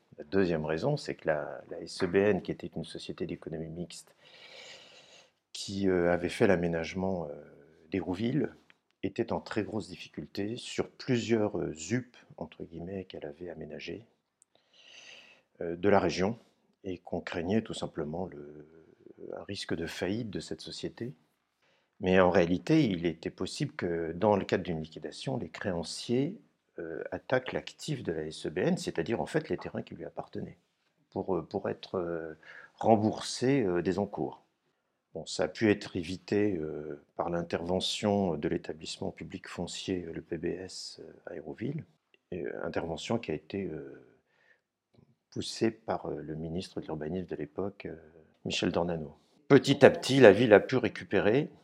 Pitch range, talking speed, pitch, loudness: 80-100 Hz, 145 wpm, 90 Hz, -31 LUFS